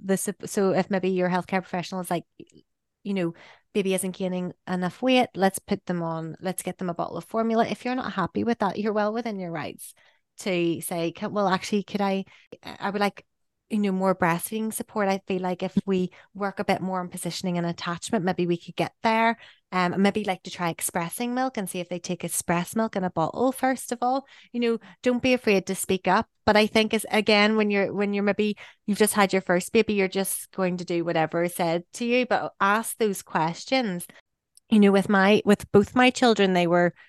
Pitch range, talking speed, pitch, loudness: 180-215 Hz, 225 wpm, 195 Hz, -25 LUFS